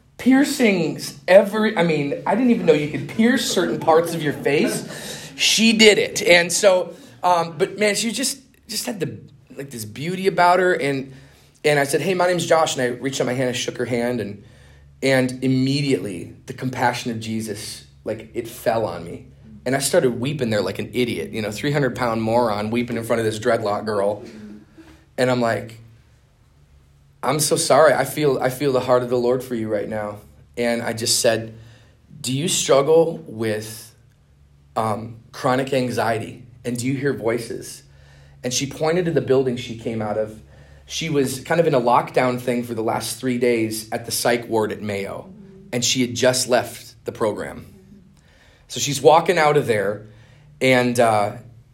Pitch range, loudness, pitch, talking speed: 115-150 Hz, -20 LUFS, 125 Hz, 190 wpm